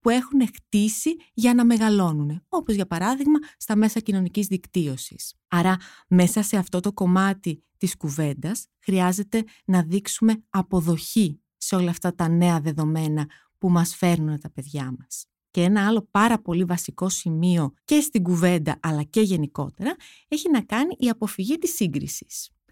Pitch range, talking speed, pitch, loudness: 170-220 Hz, 150 wpm, 185 Hz, -23 LUFS